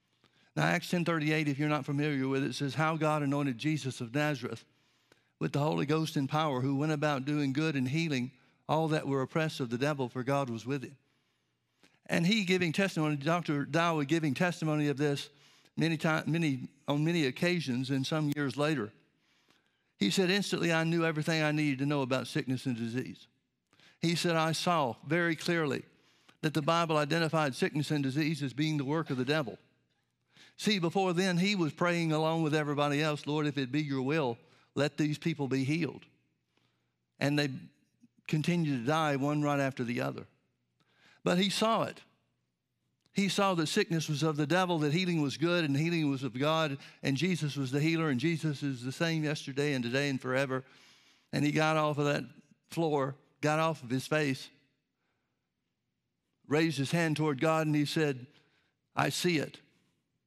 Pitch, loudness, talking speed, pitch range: 150 Hz, -31 LUFS, 185 wpm, 140-160 Hz